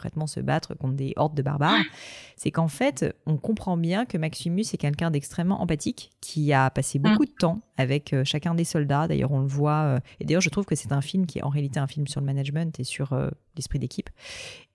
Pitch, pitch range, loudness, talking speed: 155 Hz, 140-170 Hz, -26 LUFS, 225 wpm